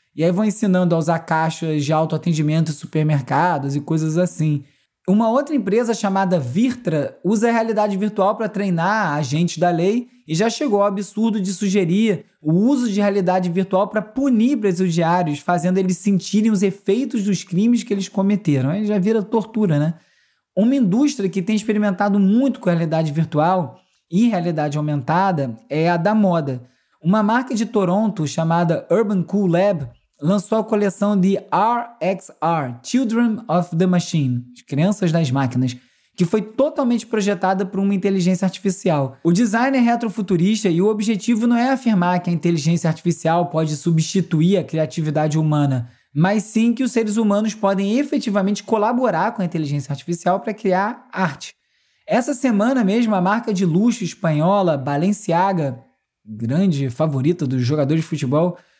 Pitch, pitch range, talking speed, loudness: 190 Hz, 160-215 Hz, 155 wpm, -19 LUFS